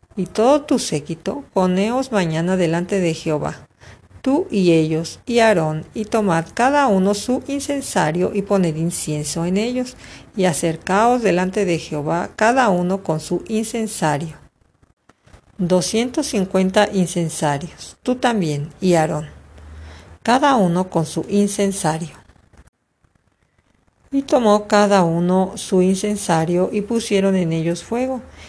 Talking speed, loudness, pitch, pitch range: 120 wpm, -19 LUFS, 185 Hz, 165-220 Hz